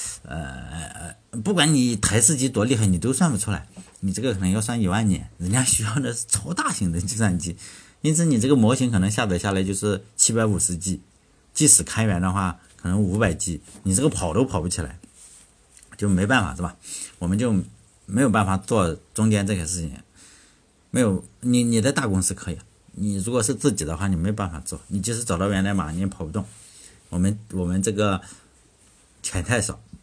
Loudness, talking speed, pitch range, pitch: -22 LUFS, 290 characters per minute, 90-110 Hz, 100 Hz